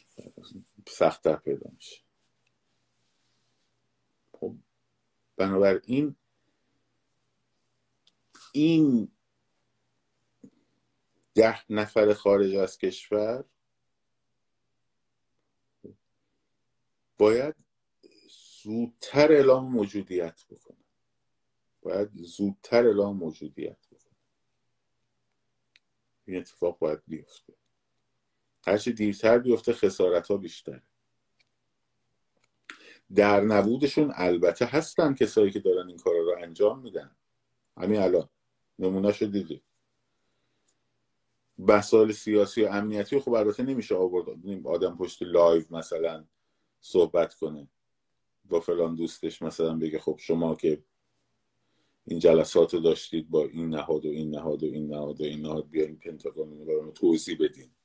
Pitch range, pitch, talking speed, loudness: 85-130 Hz, 105 Hz, 90 wpm, -26 LUFS